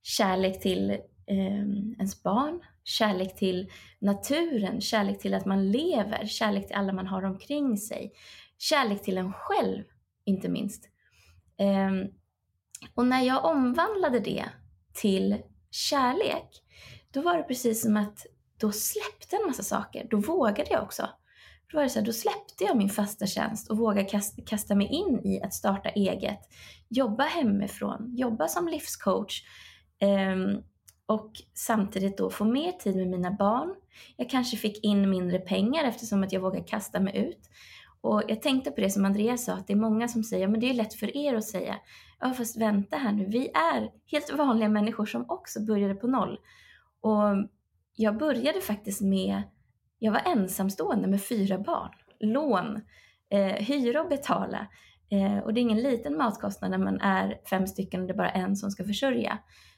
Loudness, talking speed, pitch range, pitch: -28 LUFS, 170 wpm, 195-245 Hz, 210 Hz